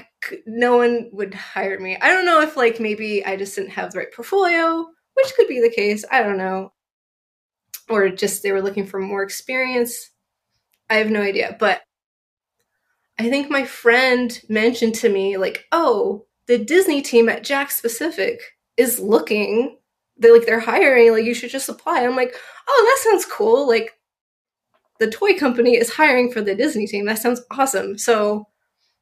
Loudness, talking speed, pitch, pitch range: -18 LUFS, 175 wpm, 240 Hz, 215-305 Hz